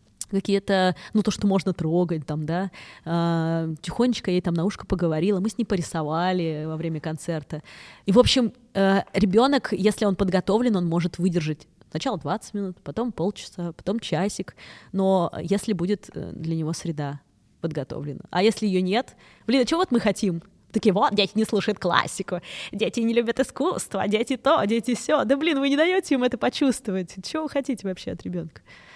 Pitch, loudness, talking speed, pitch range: 195 Hz, -24 LUFS, 170 wpm, 170-225 Hz